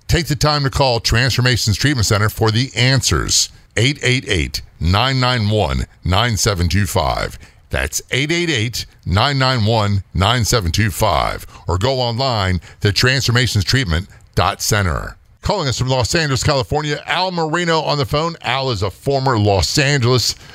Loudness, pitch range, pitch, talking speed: -16 LUFS, 100-135 Hz, 120 Hz, 115 wpm